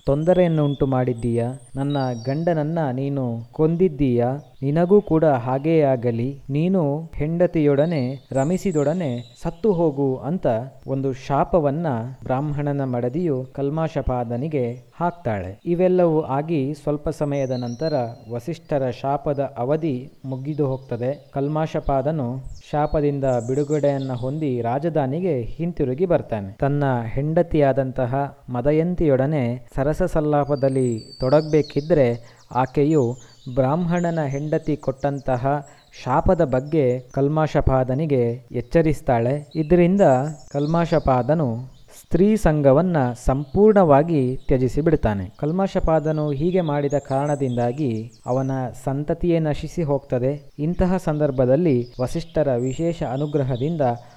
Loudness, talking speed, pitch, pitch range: -21 LUFS, 80 wpm, 140 Hz, 130-155 Hz